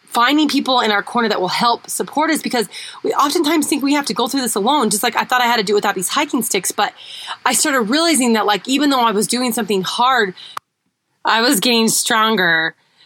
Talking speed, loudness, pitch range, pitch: 235 wpm, -16 LUFS, 215-275 Hz, 240 Hz